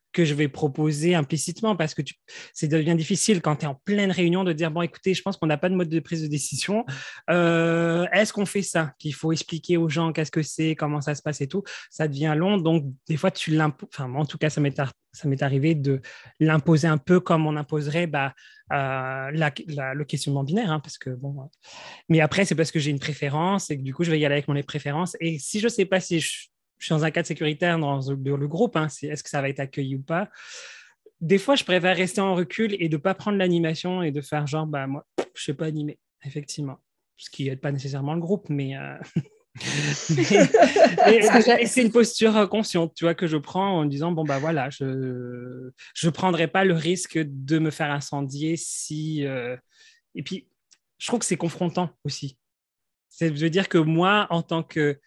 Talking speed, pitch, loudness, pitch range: 235 wpm, 160 Hz, -24 LUFS, 145-180 Hz